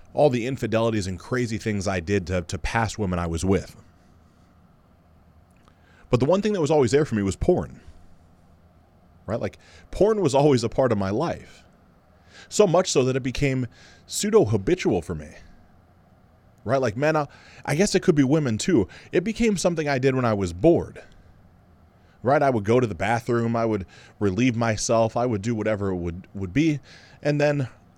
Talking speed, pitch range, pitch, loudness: 190 wpm, 90-130 Hz, 105 Hz, -23 LUFS